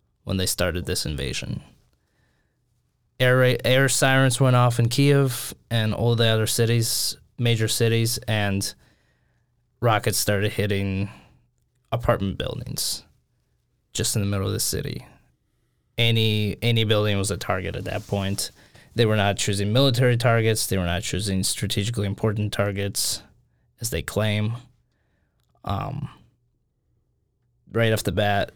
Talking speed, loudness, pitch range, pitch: 130 wpm, -23 LUFS, 100-120 Hz, 110 Hz